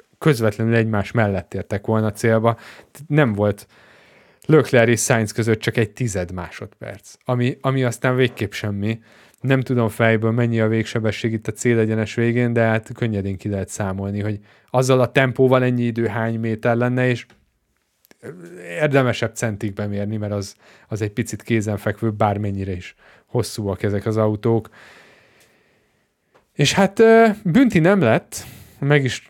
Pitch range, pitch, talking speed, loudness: 105-125 Hz, 115 Hz, 140 wpm, -19 LUFS